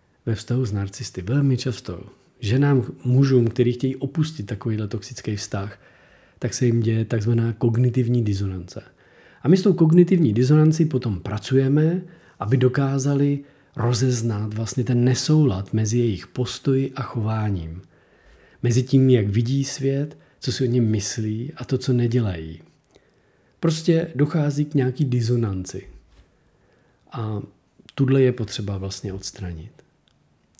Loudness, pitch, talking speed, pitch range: -22 LUFS, 125 Hz, 130 wpm, 110-135 Hz